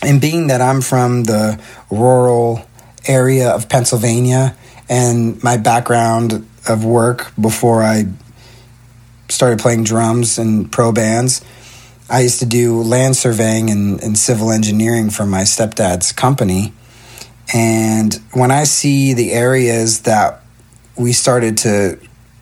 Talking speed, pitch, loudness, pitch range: 125 wpm, 120 Hz, -13 LUFS, 110-125 Hz